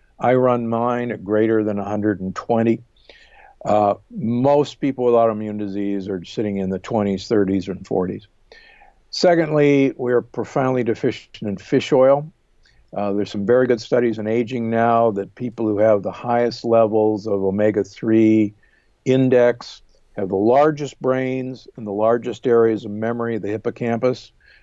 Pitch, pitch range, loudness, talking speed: 115 Hz, 105-125 Hz, -19 LUFS, 145 wpm